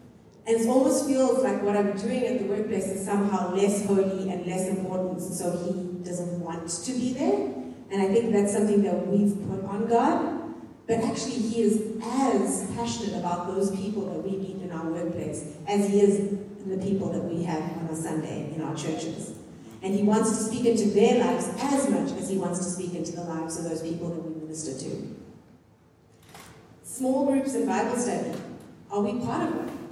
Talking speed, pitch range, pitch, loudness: 200 wpm, 180-230 Hz, 200 Hz, -27 LUFS